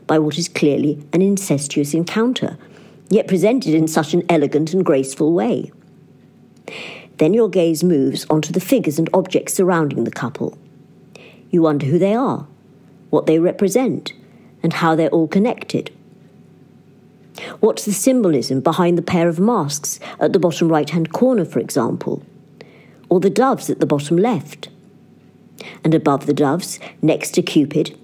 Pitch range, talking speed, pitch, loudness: 150-190 Hz, 150 wpm, 165 Hz, -17 LUFS